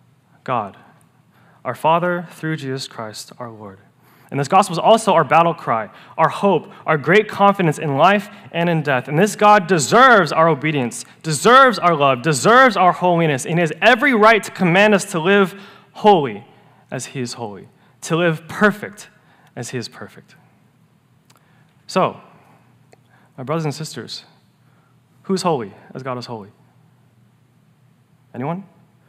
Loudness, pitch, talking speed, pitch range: -16 LUFS, 160 Hz, 145 wpm, 135-195 Hz